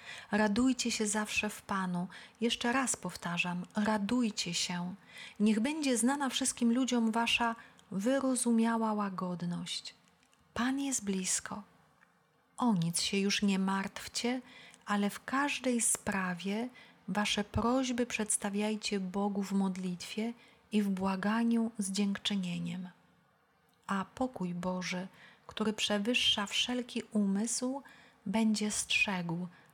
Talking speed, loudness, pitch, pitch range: 105 wpm, -33 LUFS, 215 Hz, 195-235 Hz